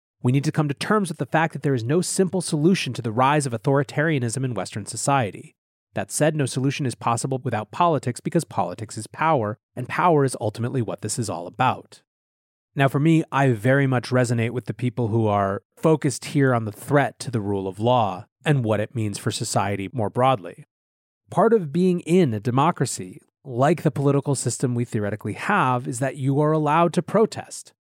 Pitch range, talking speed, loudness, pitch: 115-150 Hz, 200 wpm, -22 LUFS, 130 Hz